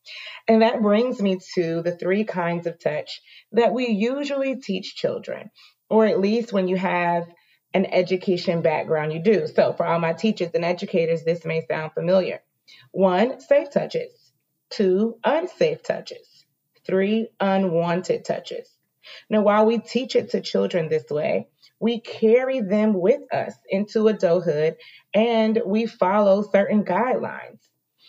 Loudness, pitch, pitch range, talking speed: -22 LUFS, 205 Hz, 175-230 Hz, 145 wpm